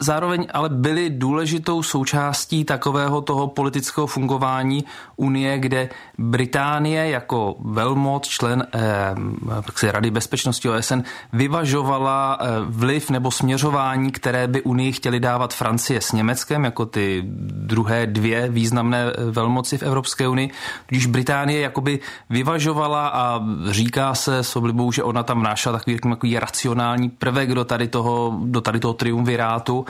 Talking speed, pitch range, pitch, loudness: 130 wpm, 120-140 Hz, 130 Hz, -21 LUFS